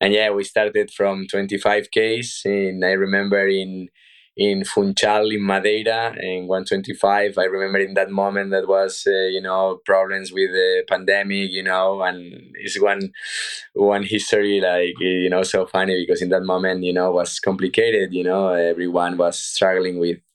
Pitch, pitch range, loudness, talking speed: 95 Hz, 90-100 Hz, -20 LUFS, 170 wpm